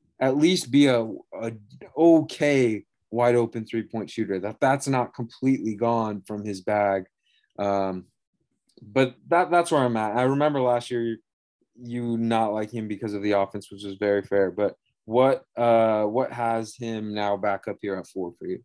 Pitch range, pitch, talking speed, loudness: 105-125 Hz, 115 Hz, 185 wpm, -24 LUFS